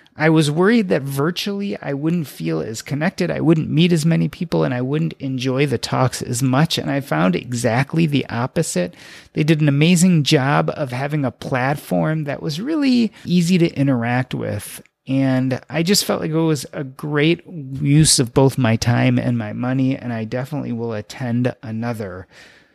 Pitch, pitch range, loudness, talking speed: 140 Hz, 125-160 Hz, -19 LUFS, 180 wpm